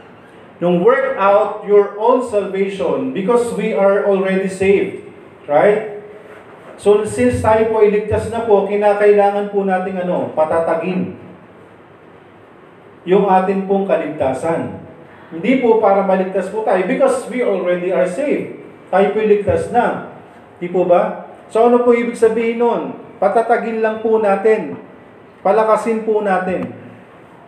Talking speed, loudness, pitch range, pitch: 130 wpm, -15 LUFS, 190-225 Hz, 205 Hz